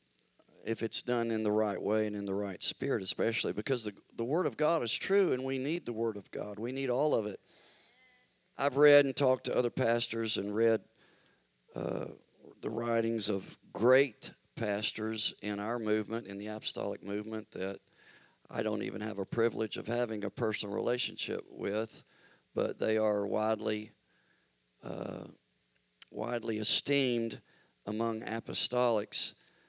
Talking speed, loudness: 155 wpm, -32 LUFS